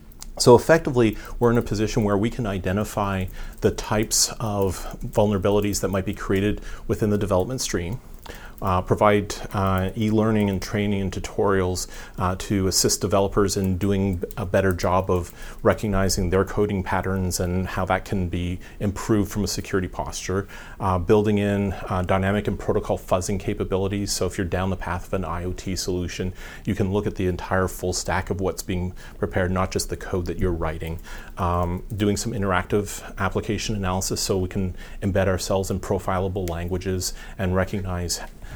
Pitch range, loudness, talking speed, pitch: 90-105 Hz, -24 LUFS, 170 wpm, 95 Hz